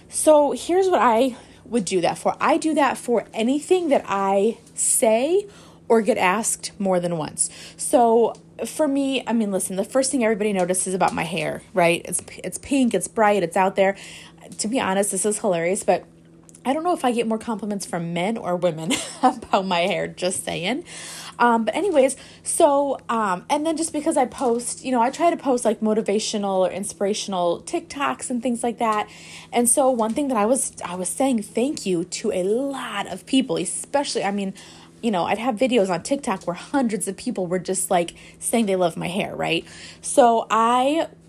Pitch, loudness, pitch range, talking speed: 225 Hz, -22 LUFS, 190-260 Hz, 200 wpm